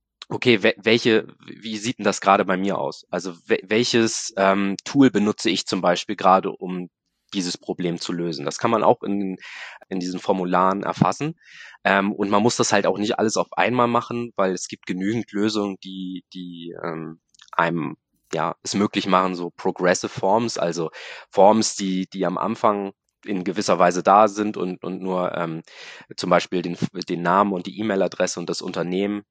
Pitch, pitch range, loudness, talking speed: 95 Hz, 90-105 Hz, -22 LUFS, 180 wpm